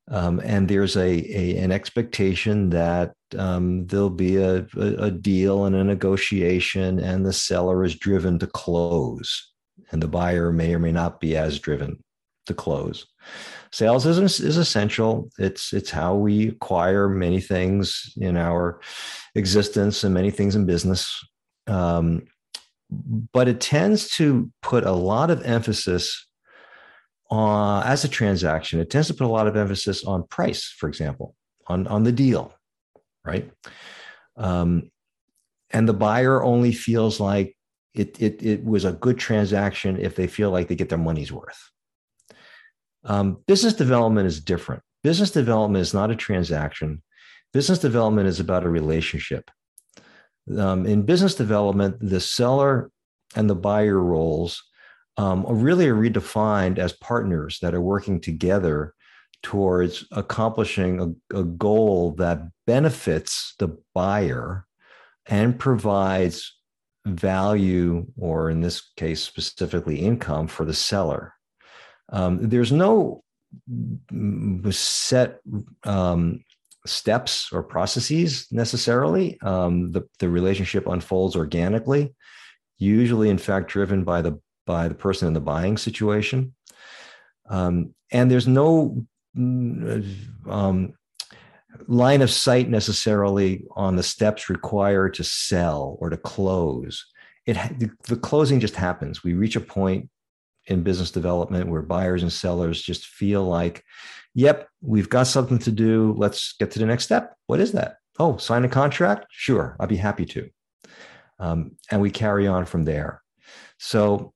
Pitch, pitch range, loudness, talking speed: 100 Hz, 90-115 Hz, -22 LUFS, 140 wpm